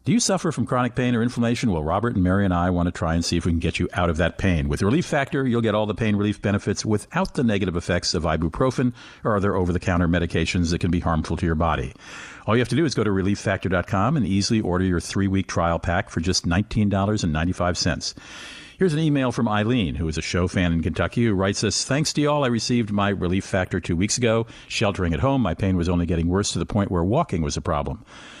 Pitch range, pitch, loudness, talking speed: 85-115 Hz, 95 Hz, -22 LUFS, 255 wpm